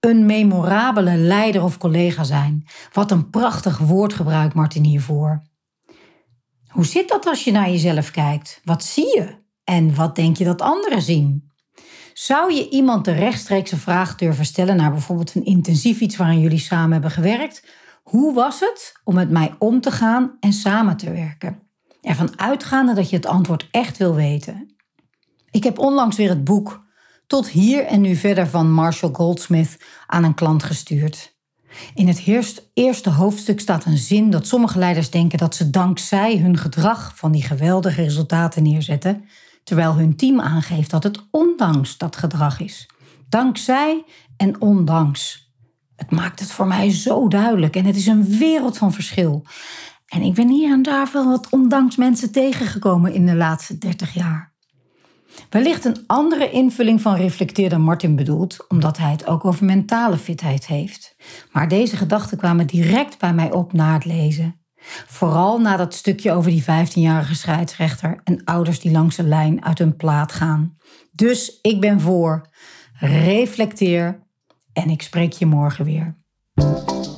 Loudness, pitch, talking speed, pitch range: -18 LUFS, 180 Hz, 165 wpm, 160-215 Hz